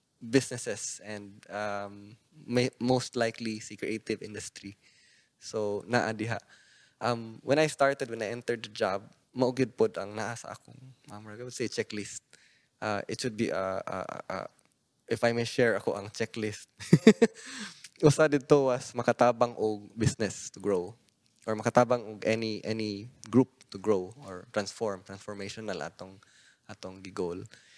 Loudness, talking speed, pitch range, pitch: -30 LUFS, 135 wpm, 105-125 Hz, 115 Hz